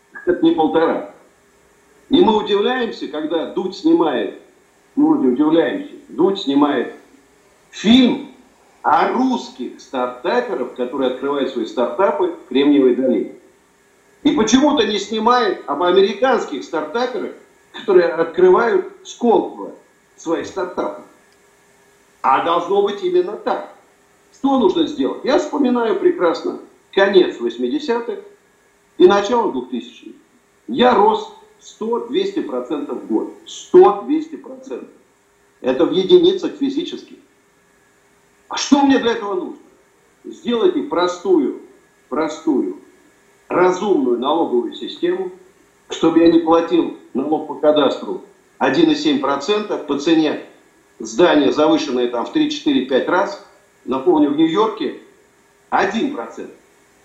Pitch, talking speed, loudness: 300 Hz, 100 wpm, -17 LUFS